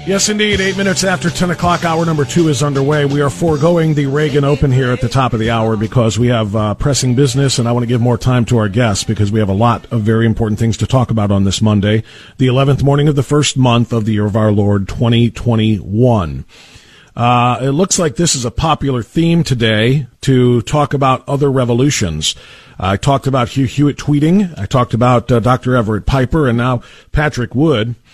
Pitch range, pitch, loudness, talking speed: 115-145 Hz, 125 Hz, -13 LUFS, 220 wpm